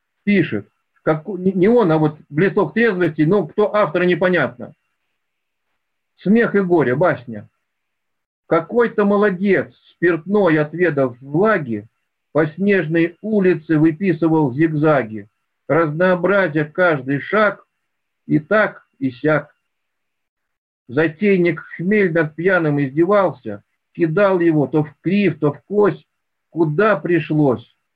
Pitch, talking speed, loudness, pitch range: 170 Hz, 105 wpm, -17 LUFS, 155-195 Hz